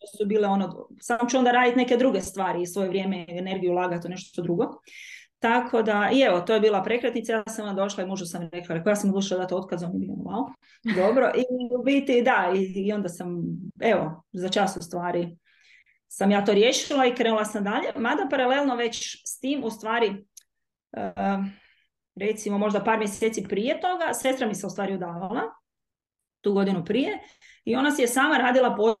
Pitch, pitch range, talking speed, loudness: 210 Hz, 190-245 Hz, 190 wpm, -25 LUFS